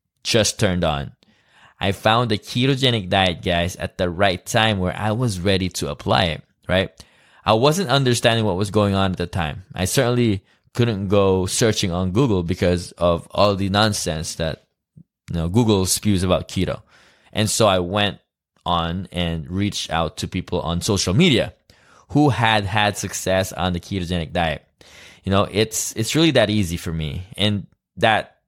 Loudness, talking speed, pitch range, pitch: -20 LUFS, 175 wpm, 90-110 Hz, 100 Hz